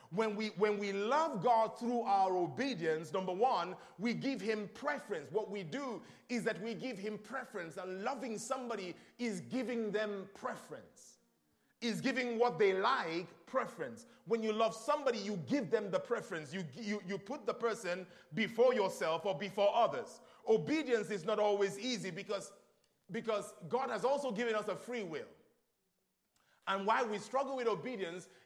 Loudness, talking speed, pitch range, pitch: -37 LUFS, 165 wpm, 200-245 Hz, 220 Hz